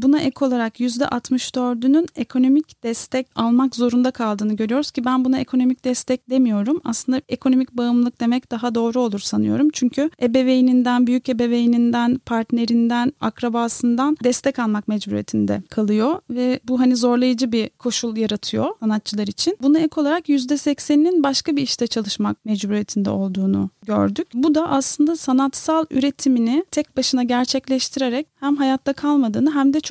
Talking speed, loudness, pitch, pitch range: 135 wpm, -19 LUFS, 255 Hz, 235-275 Hz